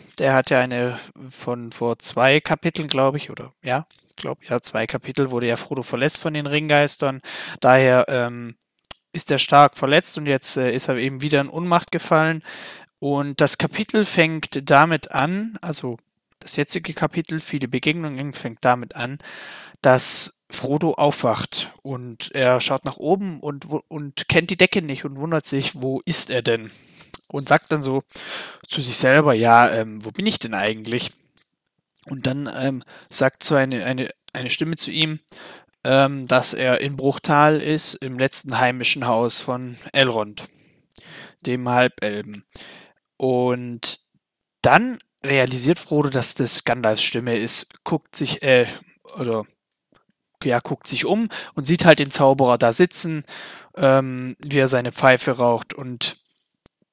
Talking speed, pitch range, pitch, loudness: 155 wpm, 125-155 Hz, 135 Hz, -20 LUFS